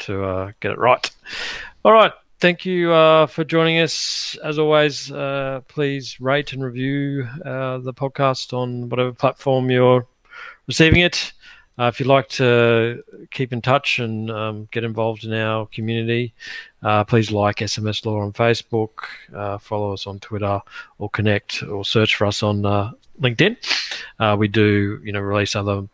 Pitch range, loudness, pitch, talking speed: 105-135 Hz, -19 LUFS, 120 Hz, 165 wpm